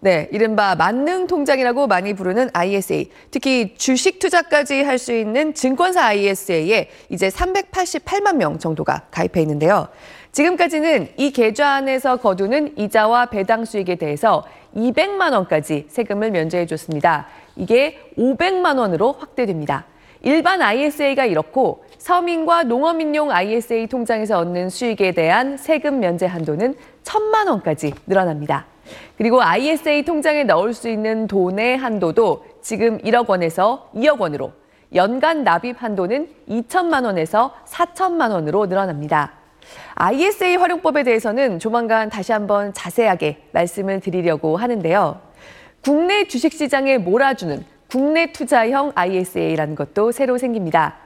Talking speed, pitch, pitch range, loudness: 310 characters per minute, 240 Hz, 190-300 Hz, -18 LUFS